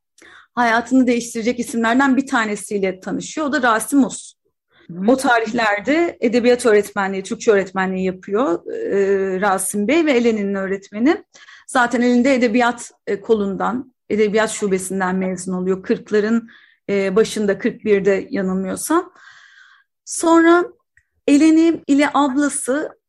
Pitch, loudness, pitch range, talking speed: 235 Hz, -18 LUFS, 200-275 Hz, 105 wpm